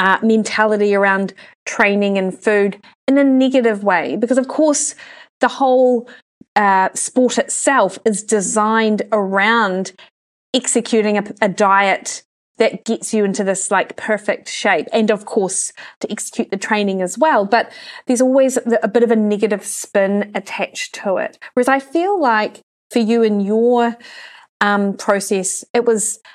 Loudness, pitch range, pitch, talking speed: -16 LUFS, 200-245 Hz, 220 Hz, 150 wpm